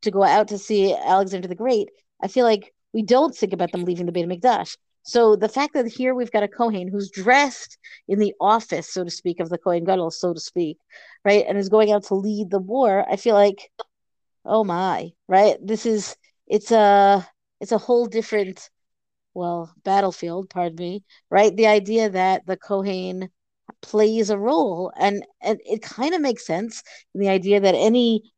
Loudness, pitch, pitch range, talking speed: -21 LUFS, 205 Hz, 185-220 Hz, 195 wpm